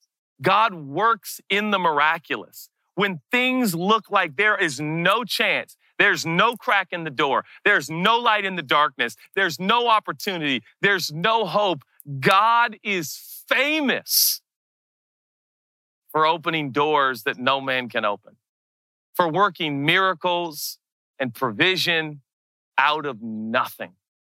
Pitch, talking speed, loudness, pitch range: 175 Hz, 125 wpm, -21 LUFS, 150-205 Hz